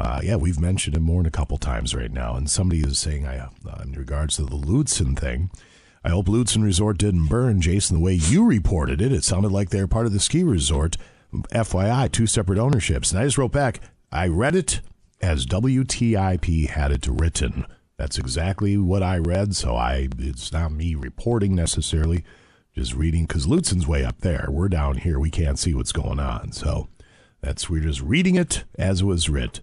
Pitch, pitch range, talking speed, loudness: 85 Hz, 75-100 Hz, 215 wpm, -22 LUFS